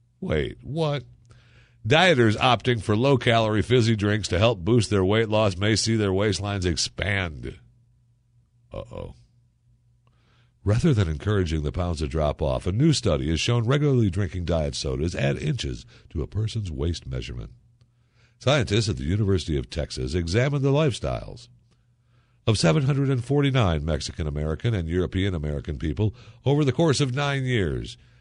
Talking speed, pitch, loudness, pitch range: 145 wpm, 115 Hz, -24 LUFS, 90-120 Hz